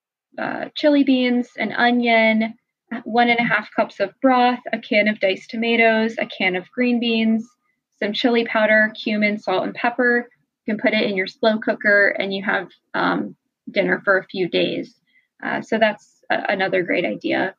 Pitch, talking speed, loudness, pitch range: 225 Hz, 180 wpm, -19 LUFS, 210-245 Hz